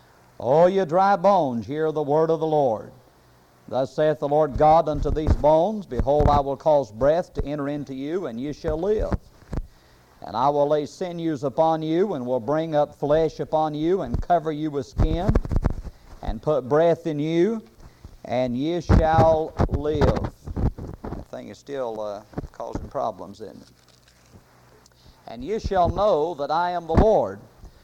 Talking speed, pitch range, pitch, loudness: 170 wpm, 130-160 Hz, 150 Hz, -23 LUFS